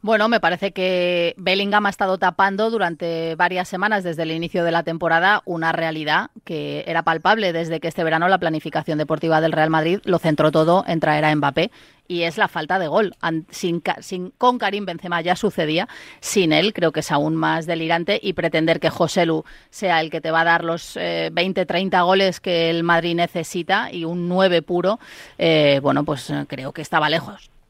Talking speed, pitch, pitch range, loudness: 200 wpm, 170 Hz, 160-185 Hz, -20 LUFS